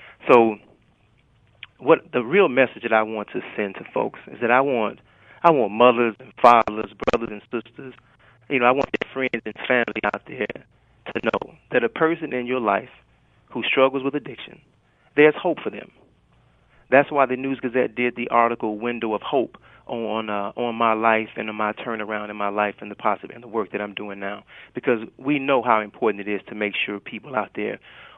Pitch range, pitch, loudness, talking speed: 105-125 Hz, 115 Hz, -22 LUFS, 205 wpm